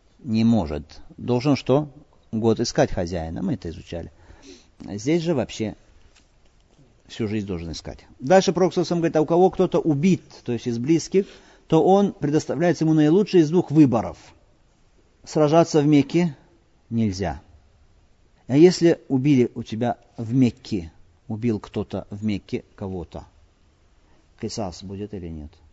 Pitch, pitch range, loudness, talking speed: 115 Hz, 90-155 Hz, -22 LUFS, 135 wpm